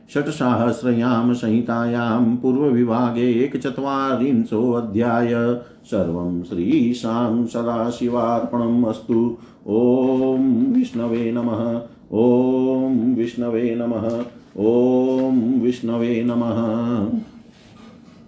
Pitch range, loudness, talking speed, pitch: 115-125 Hz, -20 LUFS, 65 wpm, 120 Hz